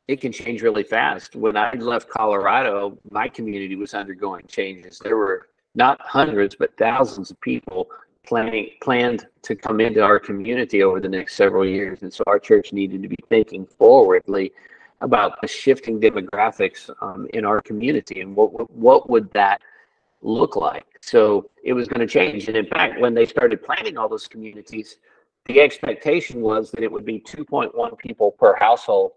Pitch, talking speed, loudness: 175 Hz, 180 wpm, -19 LUFS